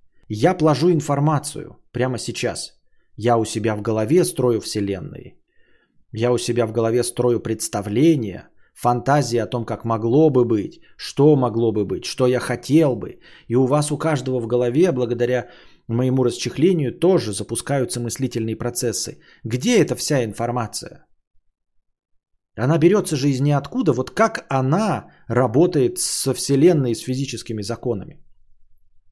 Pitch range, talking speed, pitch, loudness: 115-145 Hz, 140 wpm, 125 Hz, -20 LUFS